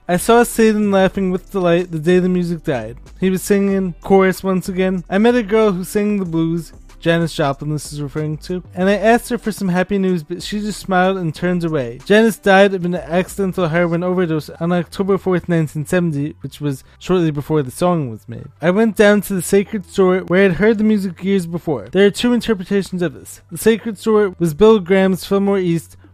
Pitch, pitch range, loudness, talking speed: 185 Hz, 165-200 Hz, -17 LUFS, 215 wpm